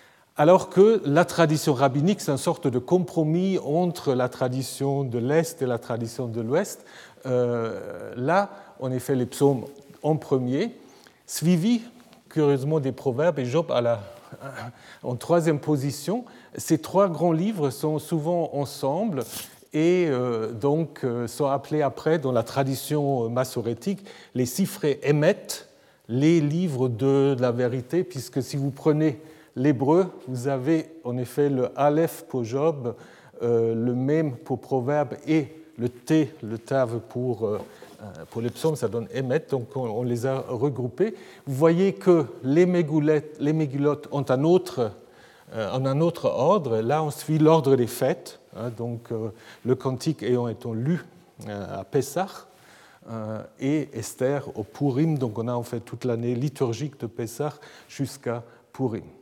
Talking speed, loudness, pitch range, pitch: 150 wpm, -25 LUFS, 125-160 Hz, 140 Hz